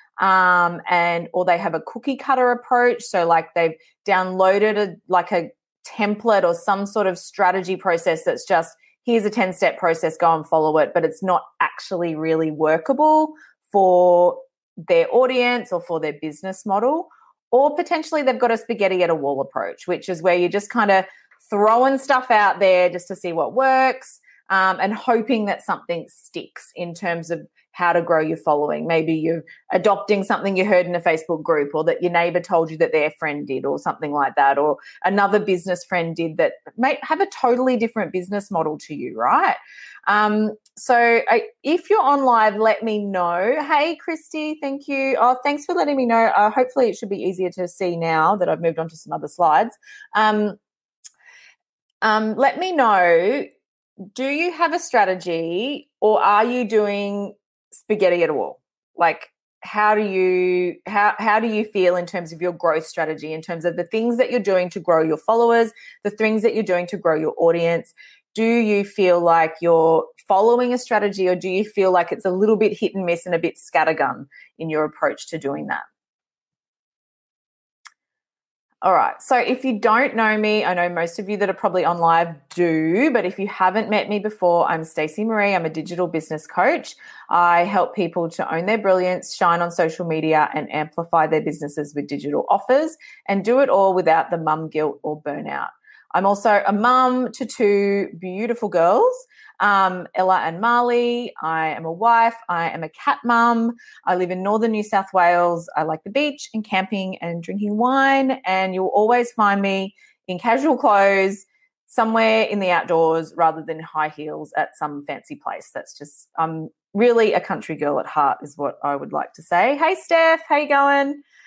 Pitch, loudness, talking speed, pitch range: 195 Hz, -19 LUFS, 190 wpm, 170-235 Hz